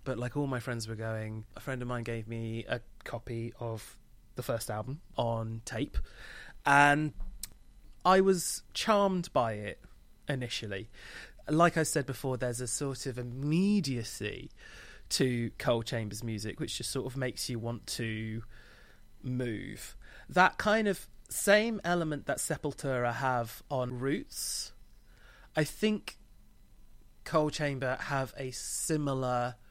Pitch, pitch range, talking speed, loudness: 125 Hz, 115-145 Hz, 135 wpm, -32 LUFS